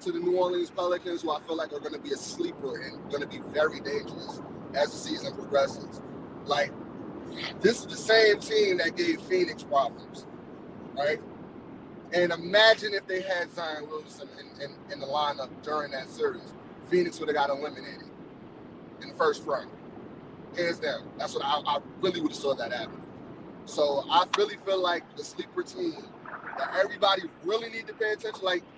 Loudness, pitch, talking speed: -29 LUFS, 190 Hz, 185 wpm